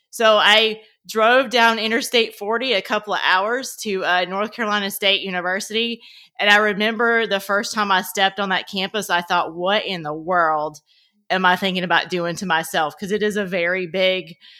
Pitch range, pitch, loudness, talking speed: 180-215 Hz, 195 Hz, -19 LUFS, 190 wpm